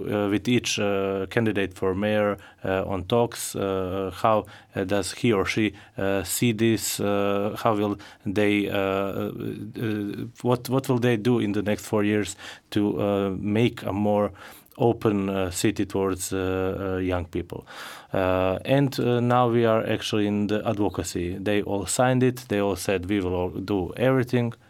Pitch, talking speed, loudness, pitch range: 105 Hz, 175 wpm, -25 LUFS, 95-115 Hz